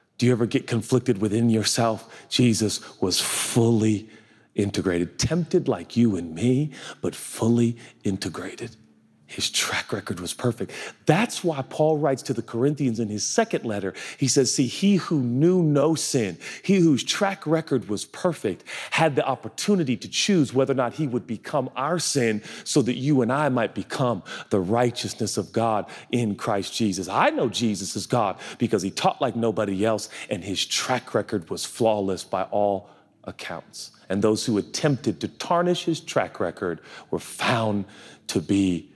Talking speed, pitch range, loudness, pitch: 170 wpm, 105-140 Hz, -24 LUFS, 120 Hz